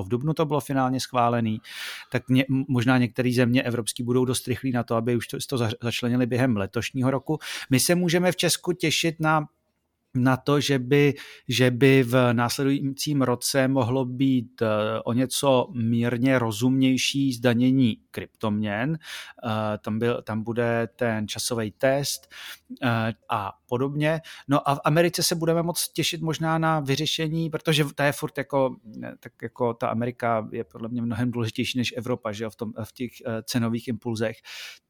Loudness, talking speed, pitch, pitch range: -24 LUFS, 160 wpm, 125 Hz, 120-140 Hz